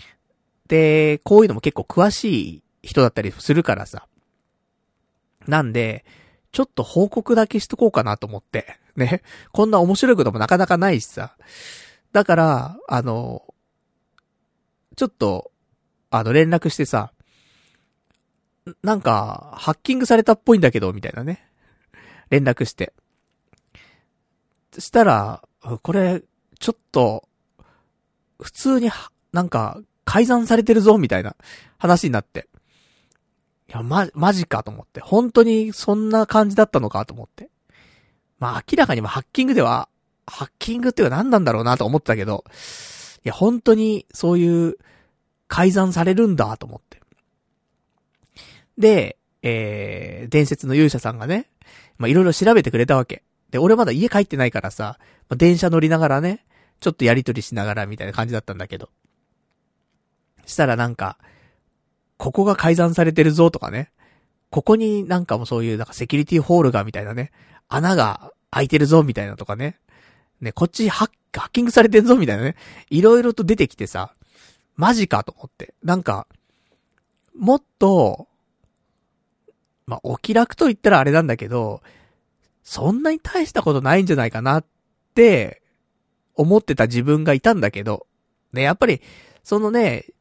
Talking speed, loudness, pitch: 305 characters per minute, -18 LUFS, 170 Hz